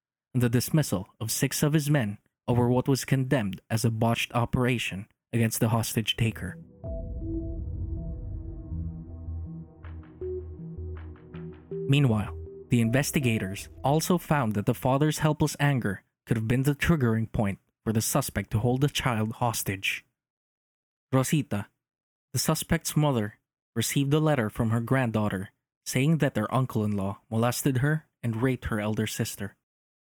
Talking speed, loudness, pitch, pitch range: 135 wpm, -27 LUFS, 115 Hz, 100-140 Hz